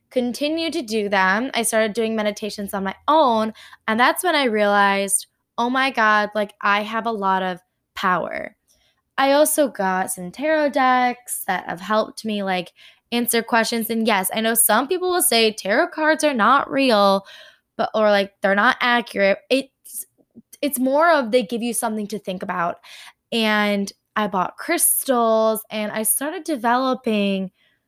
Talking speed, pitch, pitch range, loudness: 165 wpm, 225 Hz, 205-265 Hz, -20 LUFS